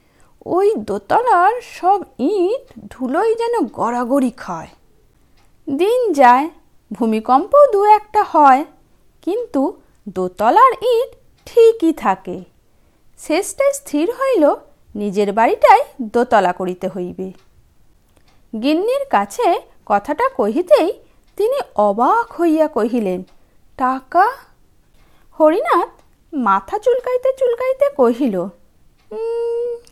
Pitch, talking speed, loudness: 310 Hz, 80 wpm, -16 LUFS